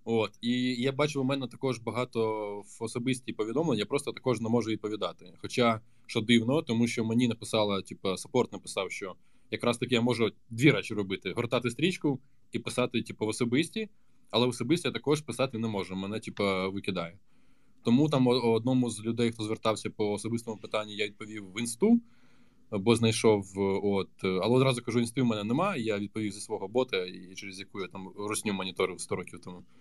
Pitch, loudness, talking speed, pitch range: 115 Hz, -30 LUFS, 185 wpm, 105-125 Hz